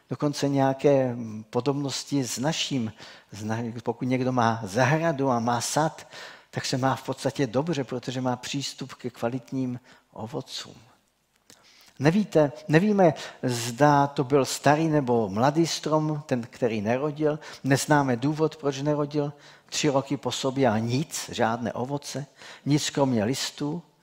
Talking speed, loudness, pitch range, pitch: 125 wpm, -26 LUFS, 125-150 Hz, 135 Hz